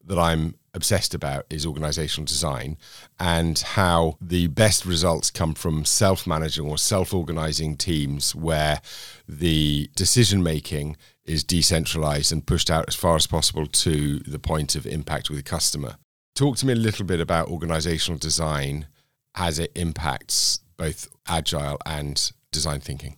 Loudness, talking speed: -23 LUFS, 150 wpm